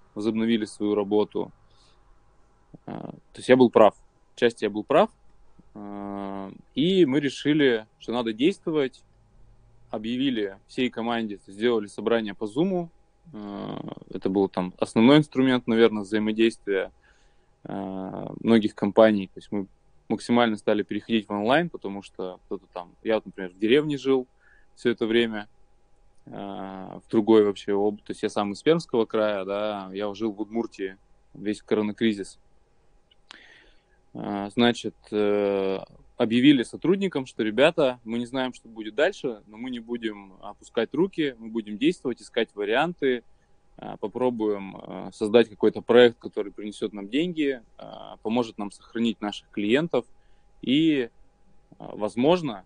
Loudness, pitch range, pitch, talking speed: -25 LUFS, 100-120 Hz, 110 Hz, 125 wpm